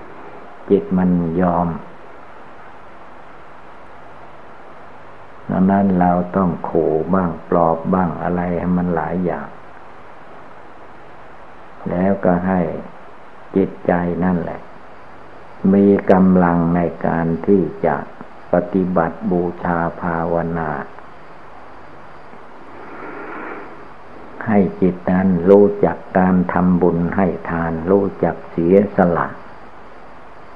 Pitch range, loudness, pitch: 85-95 Hz, -17 LUFS, 90 Hz